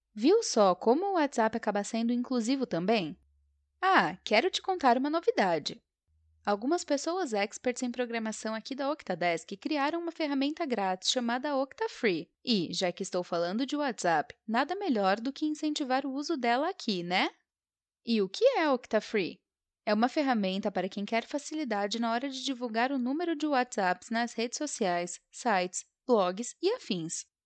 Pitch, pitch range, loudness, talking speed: 240 Hz, 200-285 Hz, -30 LUFS, 160 wpm